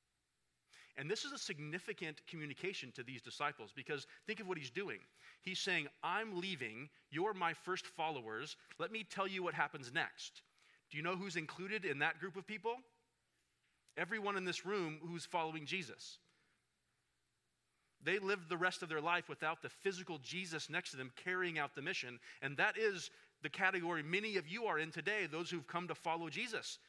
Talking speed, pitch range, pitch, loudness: 185 wpm, 155-195 Hz, 175 Hz, -42 LUFS